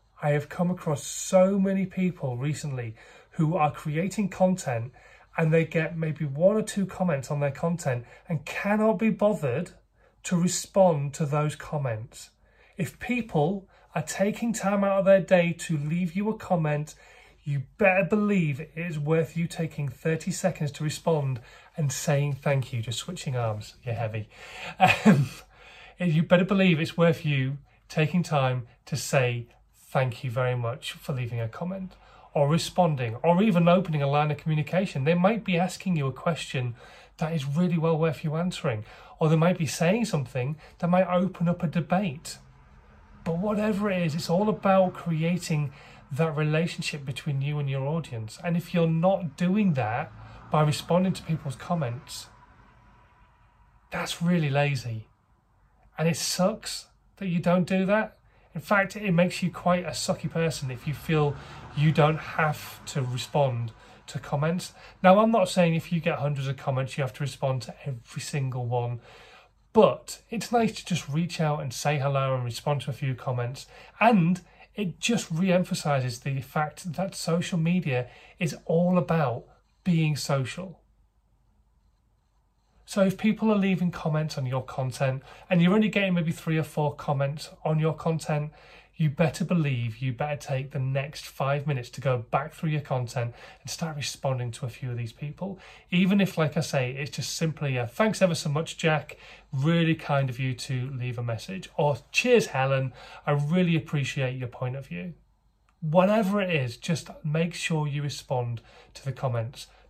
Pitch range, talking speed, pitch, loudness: 135-175 Hz, 175 wpm, 155 Hz, -27 LUFS